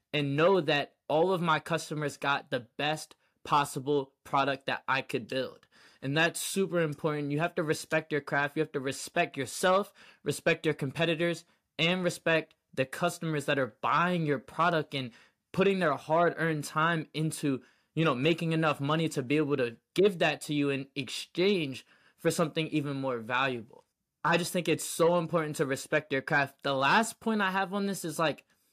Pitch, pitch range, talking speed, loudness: 155 Hz, 140-170 Hz, 185 wpm, -30 LUFS